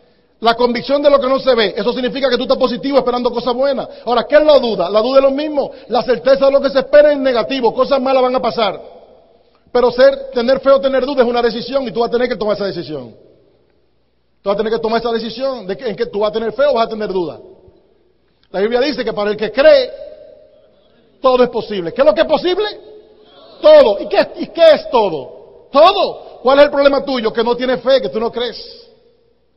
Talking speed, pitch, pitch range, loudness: 245 wpm, 260 Hz, 230-285 Hz, -14 LUFS